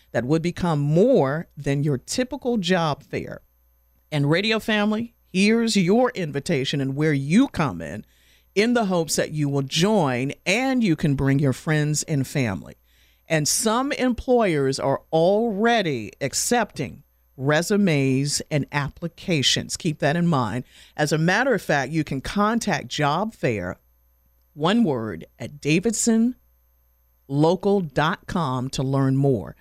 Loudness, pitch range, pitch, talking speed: -22 LUFS, 135-200 Hz, 150 Hz, 130 wpm